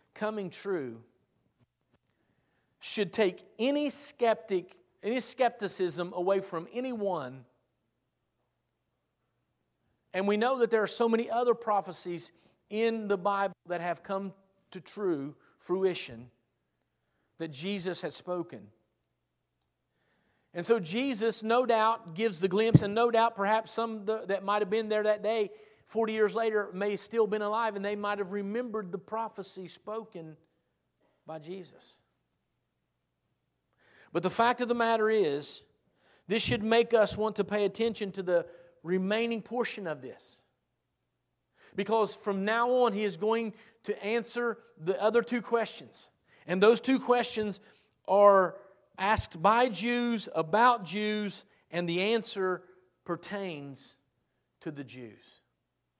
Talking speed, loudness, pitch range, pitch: 130 wpm, -30 LUFS, 175-225 Hz, 205 Hz